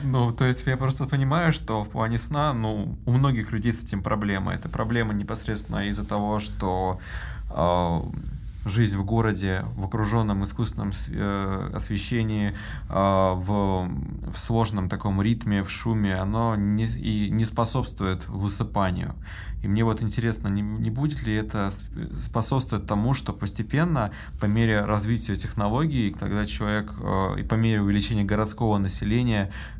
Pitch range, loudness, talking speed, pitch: 100-115 Hz, -26 LUFS, 145 wpm, 105 Hz